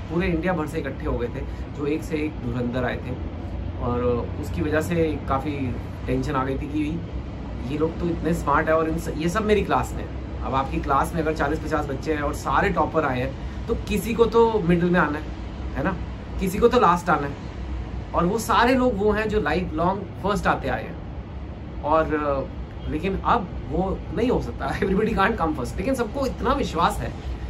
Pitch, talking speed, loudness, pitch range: 150 Hz, 215 wpm, -24 LUFS, 120-175 Hz